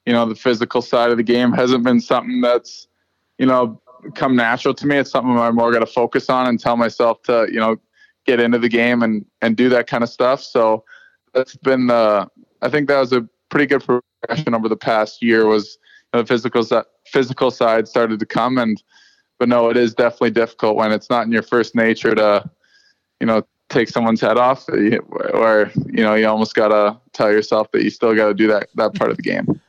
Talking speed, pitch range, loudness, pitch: 225 wpm, 110-125 Hz, -17 LUFS, 120 Hz